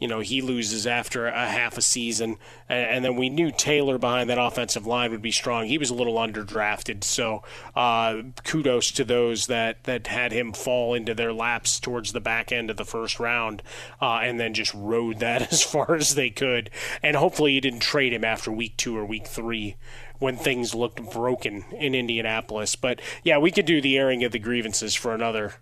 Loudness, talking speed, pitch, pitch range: -24 LUFS, 205 wpm, 120 Hz, 115-125 Hz